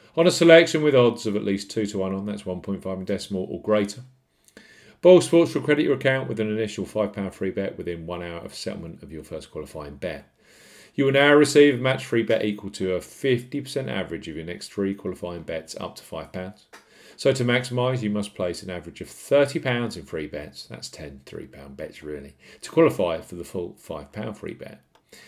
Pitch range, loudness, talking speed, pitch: 90-130 Hz, -23 LUFS, 220 wpm, 105 Hz